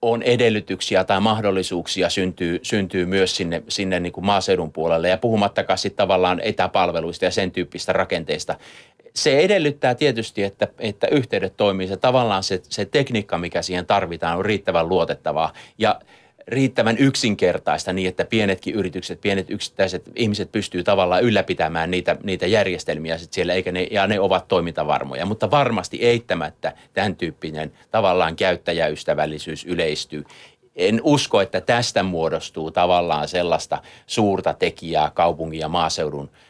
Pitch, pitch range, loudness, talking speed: 95 Hz, 85-110 Hz, -21 LUFS, 140 wpm